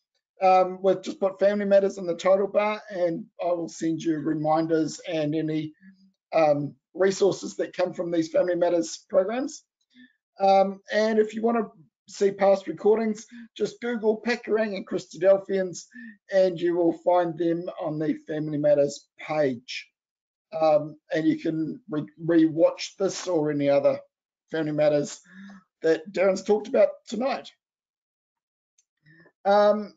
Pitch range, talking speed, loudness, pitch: 160-205 Hz, 140 wpm, -25 LUFS, 185 Hz